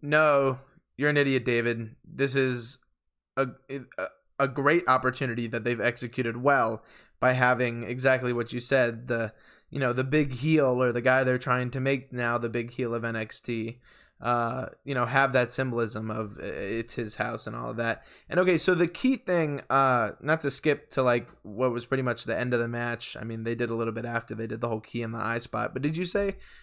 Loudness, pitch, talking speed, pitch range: -27 LUFS, 125 Hz, 220 wpm, 115-135 Hz